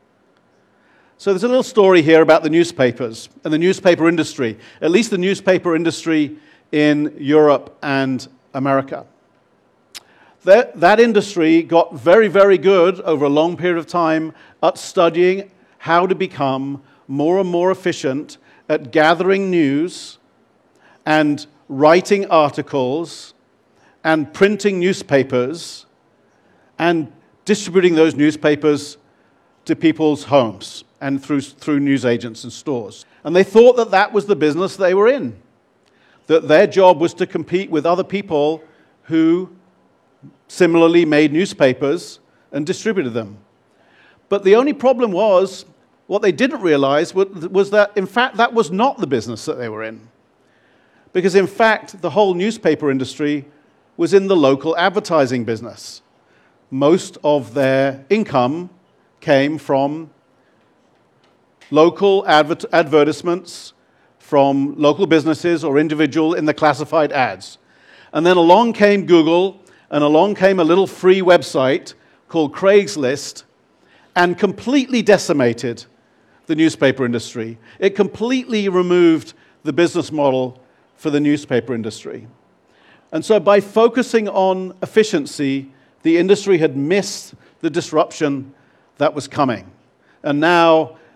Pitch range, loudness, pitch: 145-190 Hz, -16 LUFS, 160 Hz